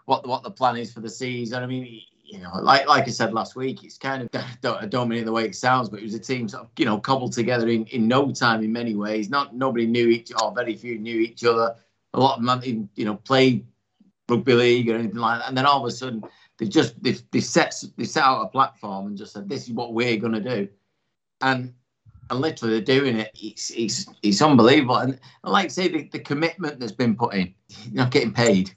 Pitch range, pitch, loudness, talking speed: 110-130 Hz, 120 Hz, -23 LUFS, 260 wpm